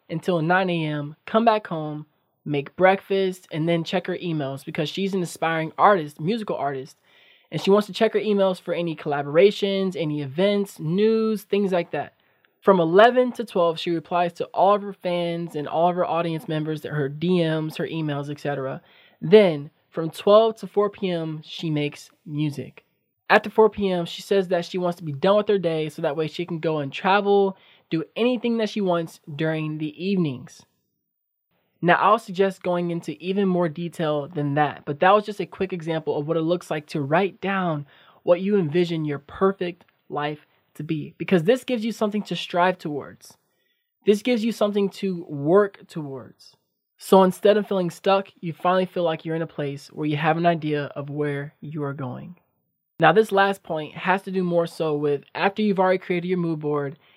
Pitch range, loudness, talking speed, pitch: 155-195 Hz, -23 LUFS, 195 wpm, 175 Hz